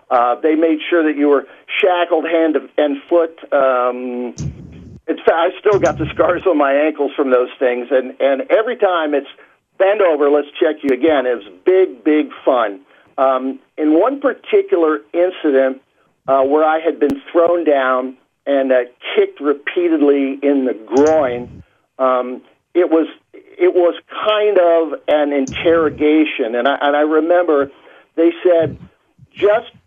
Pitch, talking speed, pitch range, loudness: 150 Hz, 155 wpm, 135-170 Hz, -15 LUFS